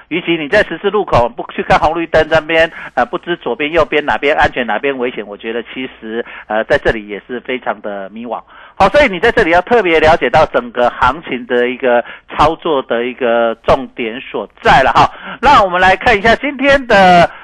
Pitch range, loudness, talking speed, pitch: 120-185 Hz, -12 LUFS, 305 characters per minute, 150 Hz